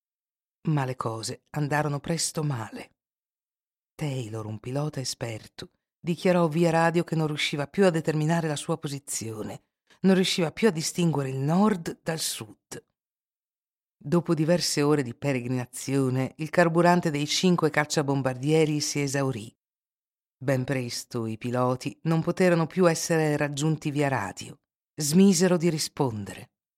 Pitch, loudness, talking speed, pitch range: 150 Hz, -26 LUFS, 130 wpm, 130-165 Hz